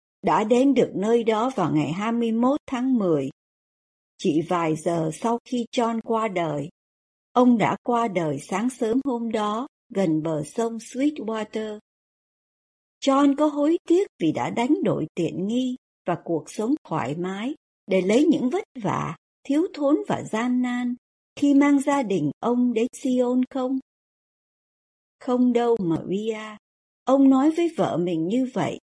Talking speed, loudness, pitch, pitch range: 155 wpm, -23 LUFS, 235 Hz, 185-260 Hz